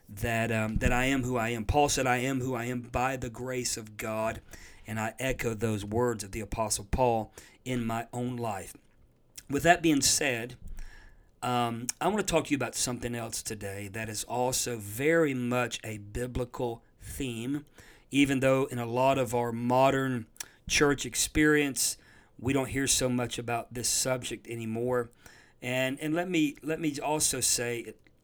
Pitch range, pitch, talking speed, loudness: 115-135 Hz, 125 Hz, 175 wpm, -29 LUFS